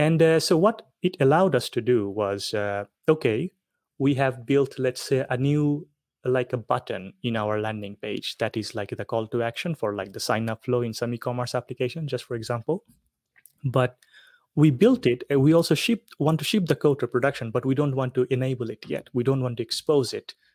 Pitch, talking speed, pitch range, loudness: 130 Hz, 215 wpm, 120-155 Hz, -25 LUFS